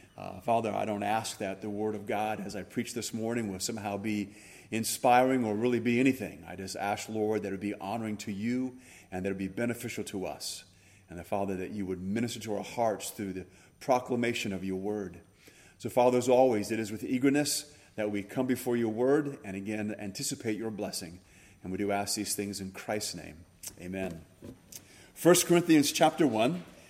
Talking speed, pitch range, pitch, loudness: 200 wpm, 95-120 Hz, 105 Hz, -31 LUFS